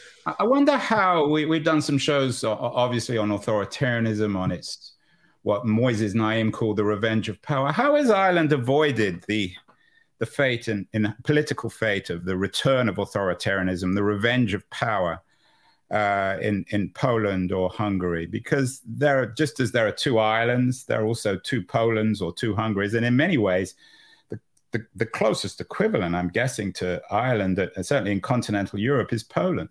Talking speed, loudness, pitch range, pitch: 170 wpm, -24 LUFS, 105-135 Hz, 110 Hz